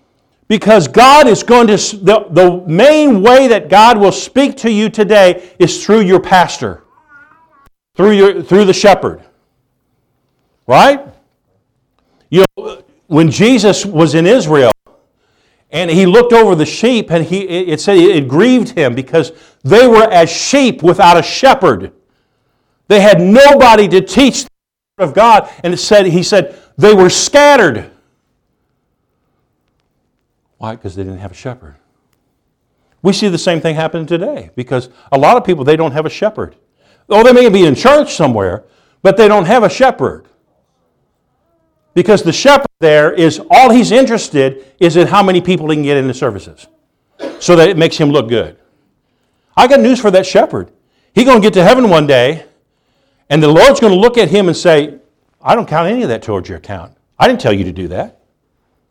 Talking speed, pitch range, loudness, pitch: 175 wpm, 155-230 Hz, -9 LUFS, 185 Hz